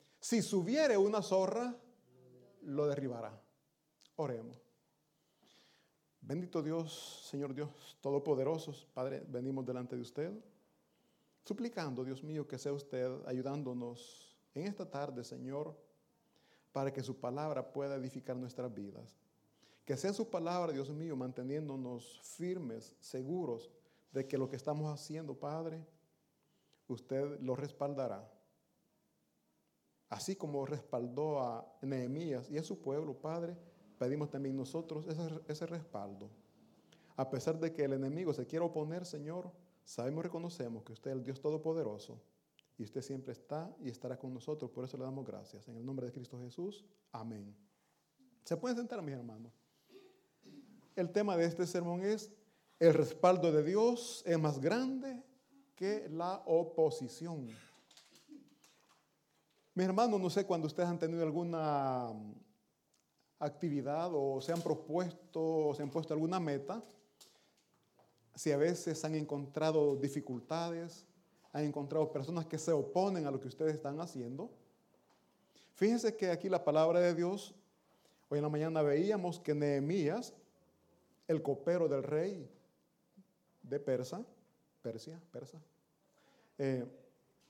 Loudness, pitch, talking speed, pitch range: -38 LUFS, 155 Hz, 130 wpm, 135-175 Hz